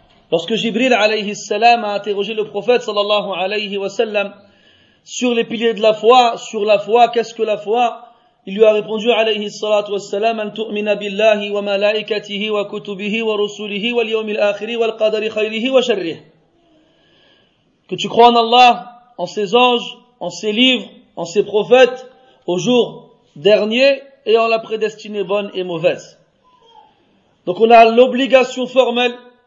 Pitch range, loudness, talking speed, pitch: 205-240 Hz, -15 LUFS, 130 wpm, 220 Hz